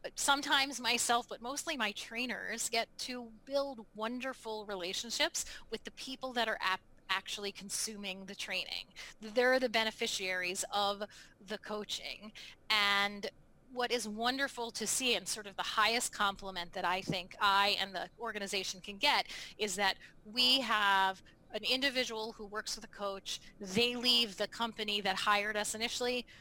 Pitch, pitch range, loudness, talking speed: 215 Hz, 200-240 Hz, -34 LUFS, 150 wpm